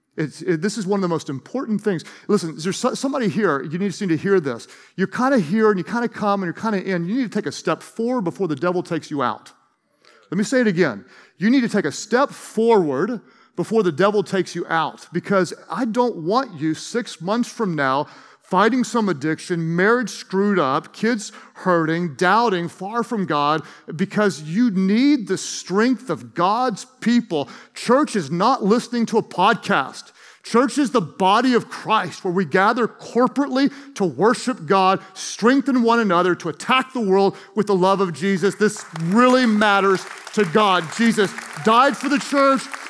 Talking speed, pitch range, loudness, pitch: 195 wpm, 180-235 Hz, -20 LUFS, 200 Hz